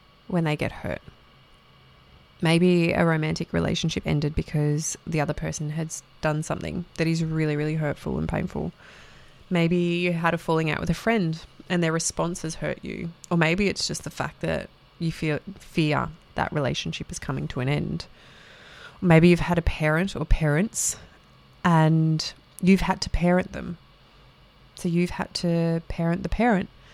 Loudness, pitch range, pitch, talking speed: -25 LUFS, 155-175 Hz, 165 Hz, 165 wpm